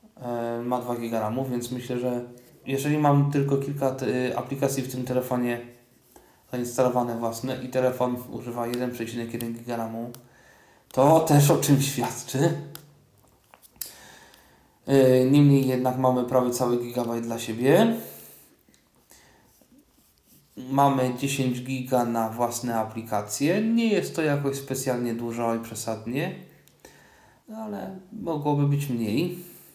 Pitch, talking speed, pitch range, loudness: 125 Hz, 105 wpm, 120-140 Hz, -25 LUFS